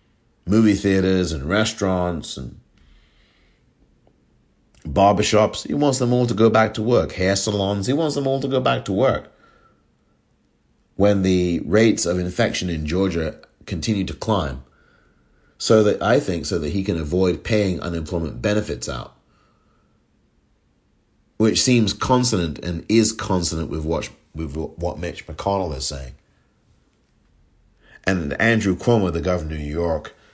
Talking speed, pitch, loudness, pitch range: 140 wpm, 95 Hz, -20 LUFS, 85-110 Hz